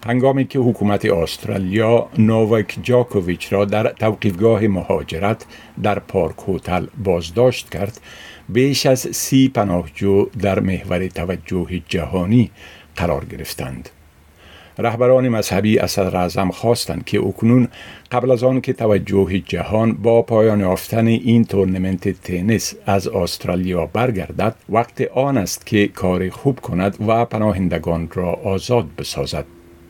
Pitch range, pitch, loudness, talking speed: 90-115 Hz, 100 Hz, -18 LUFS, 120 wpm